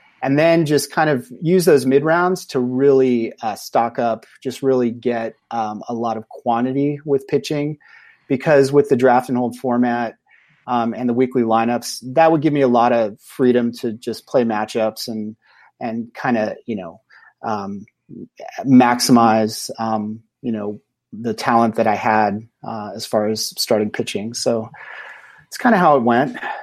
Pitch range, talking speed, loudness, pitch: 115-135 Hz, 175 wpm, -18 LUFS, 120 Hz